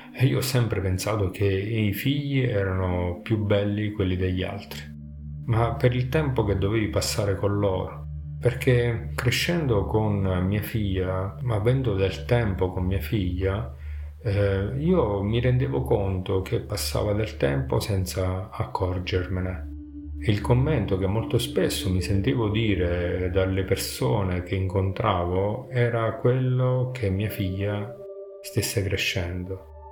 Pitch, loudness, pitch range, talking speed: 100 Hz, -25 LUFS, 90-115 Hz, 130 wpm